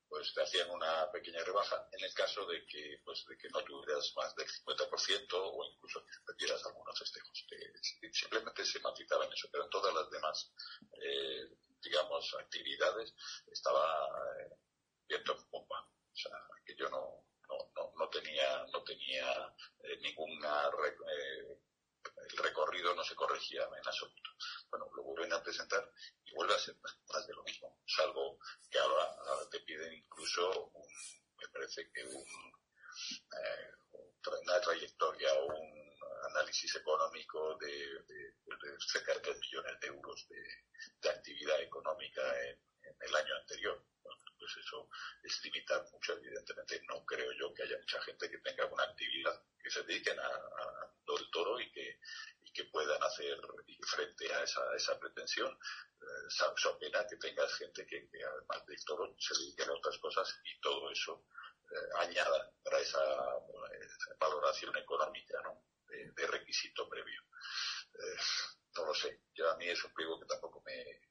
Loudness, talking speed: -40 LUFS, 160 wpm